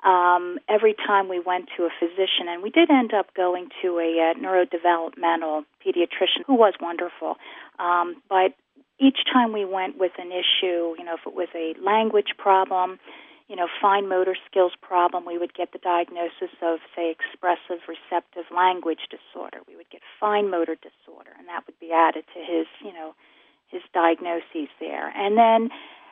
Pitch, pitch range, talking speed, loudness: 180 Hz, 170-200 Hz, 175 wpm, -23 LUFS